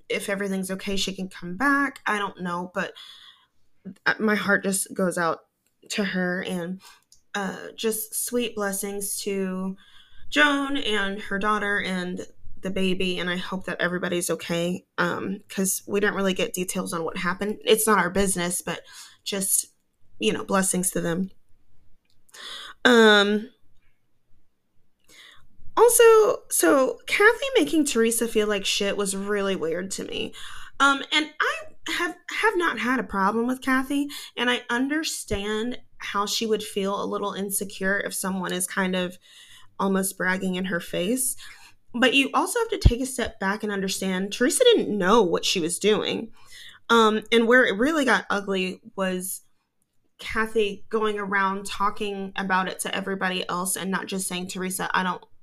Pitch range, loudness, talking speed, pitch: 185-245 Hz, -24 LUFS, 155 wpm, 200 Hz